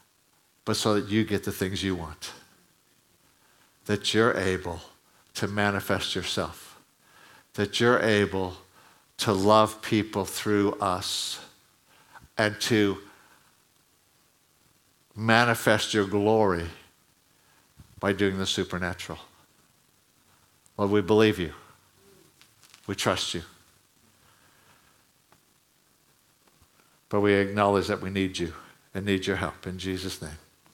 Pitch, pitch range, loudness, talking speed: 100 Hz, 95-105 Hz, -26 LUFS, 100 wpm